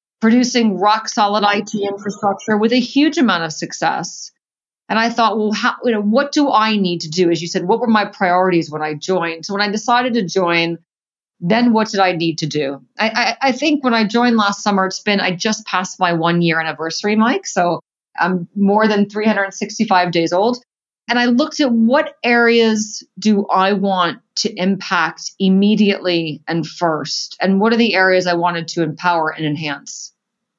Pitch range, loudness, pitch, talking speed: 175-225 Hz, -16 LUFS, 200 Hz, 190 wpm